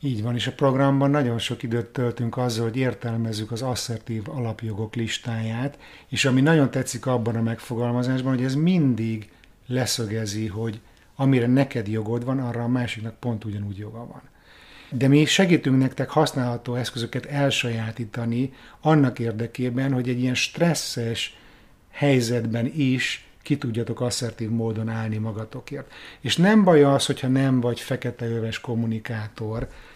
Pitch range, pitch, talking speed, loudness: 115-135 Hz, 120 Hz, 140 wpm, -24 LUFS